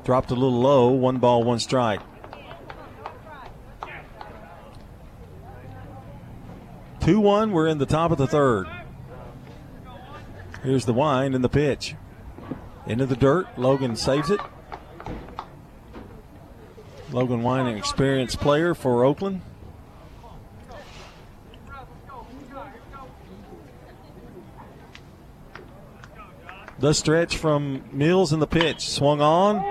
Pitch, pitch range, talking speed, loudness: 135 Hz, 125-155 Hz, 85 wpm, -22 LUFS